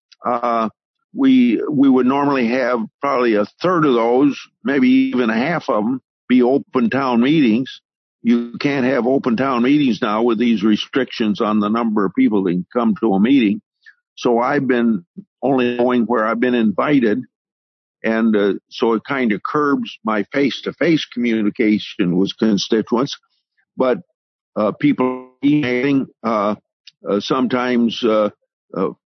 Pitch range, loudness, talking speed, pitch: 110-145 Hz, -17 LUFS, 150 wpm, 125 Hz